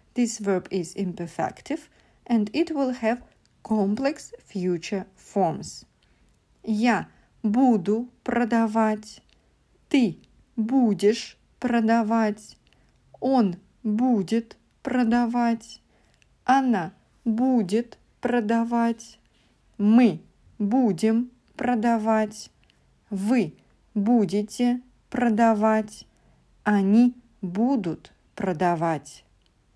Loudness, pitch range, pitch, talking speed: -24 LUFS, 205-245 Hz, 225 Hz, 65 wpm